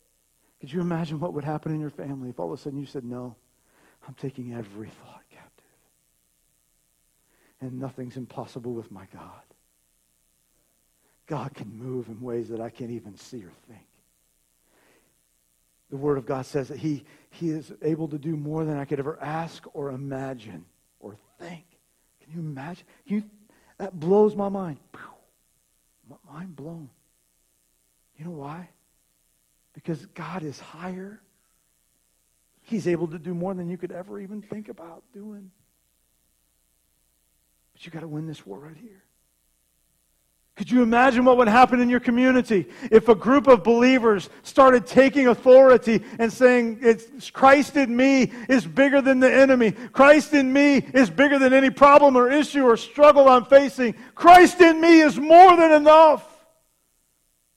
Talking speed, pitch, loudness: 155 wpm, 165 Hz, -18 LUFS